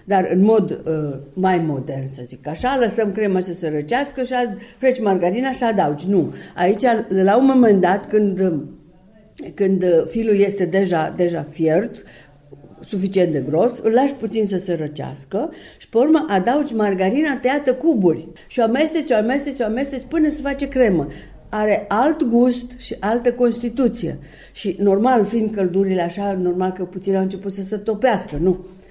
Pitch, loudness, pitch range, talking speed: 200 Hz, -19 LUFS, 175-240 Hz, 165 wpm